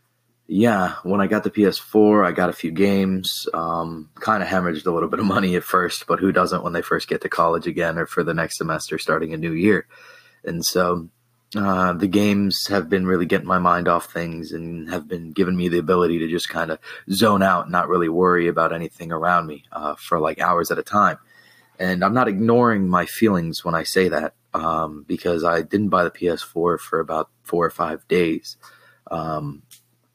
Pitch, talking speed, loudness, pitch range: 90 Hz, 210 wpm, -21 LUFS, 85-100 Hz